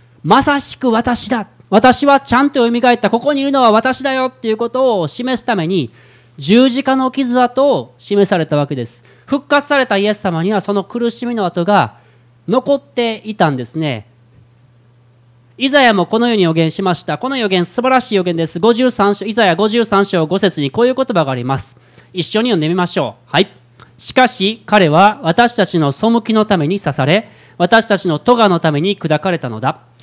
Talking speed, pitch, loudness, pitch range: 345 characters per minute, 200 Hz, -14 LUFS, 160-240 Hz